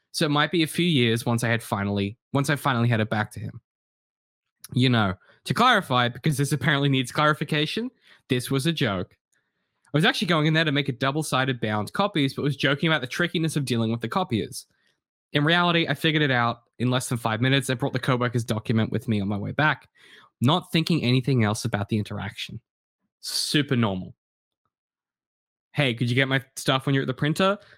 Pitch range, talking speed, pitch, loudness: 115-155 Hz, 210 wpm, 135 Hz, -24 LUFS